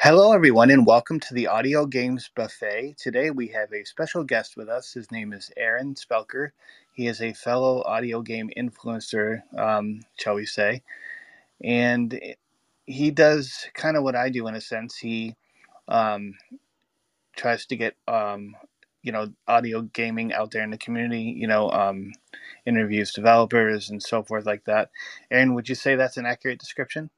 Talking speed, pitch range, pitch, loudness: 170 wpm, 110-130 Hz, 115 Hz, -23 LUFS